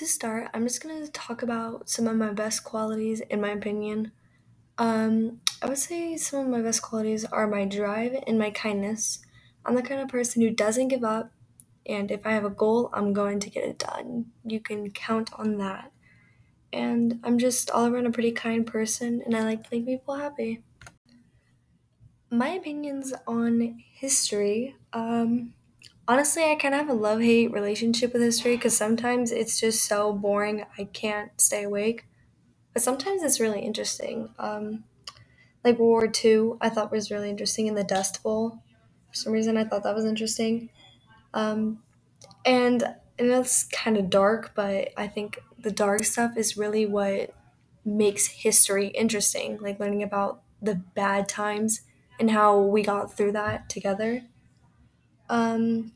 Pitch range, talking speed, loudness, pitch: 210-235 Hz, 170 wpm, -25 LUFS, 220 Hz